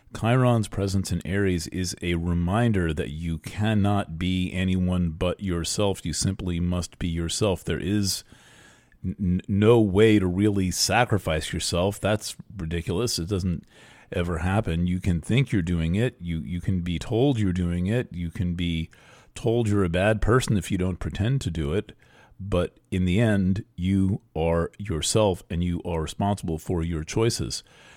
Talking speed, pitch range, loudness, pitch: 165 wpm, 85-105 Hz, -25 LUFS, 95 Hz